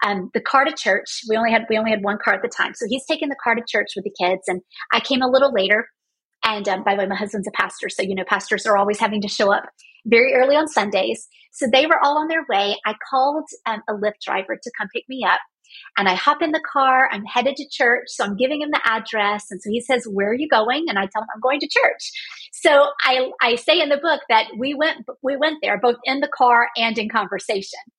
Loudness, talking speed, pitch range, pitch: -19 LUFS, 270 wpm, 205-270 Hz, 230 Hz